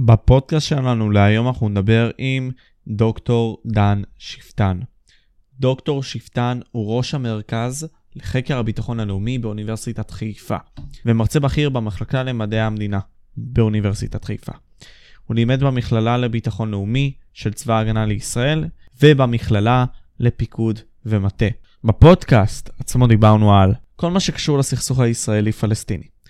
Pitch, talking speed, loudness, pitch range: 115 Hz, 105 wpm, -19 LUFS, 110-130 Hz